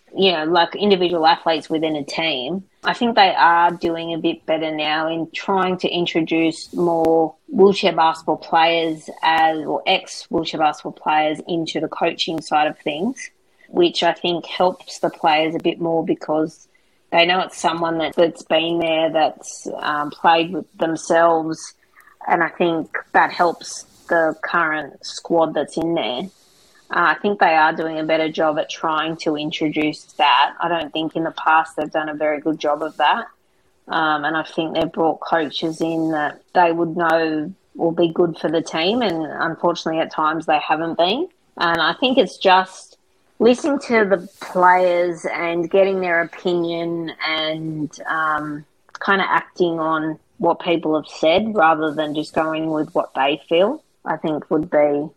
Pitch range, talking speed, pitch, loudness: 155-175 Hz, 170 wpm, 165 Hz, -19 LUFS